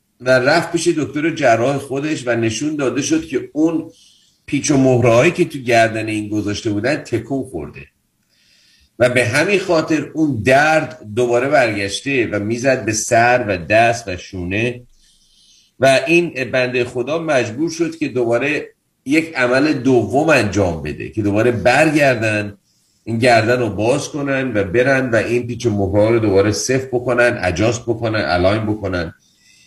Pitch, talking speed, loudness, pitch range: 125 Hz, 150 wpm, -16 LUFS, 110-145 Hz